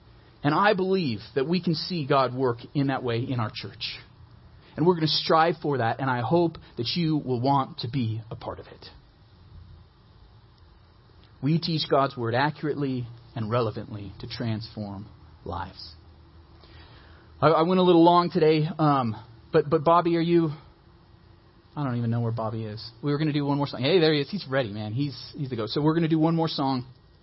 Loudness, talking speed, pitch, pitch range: -25 LUFS, 205 wpm, 125 Hz, 110-155 Hz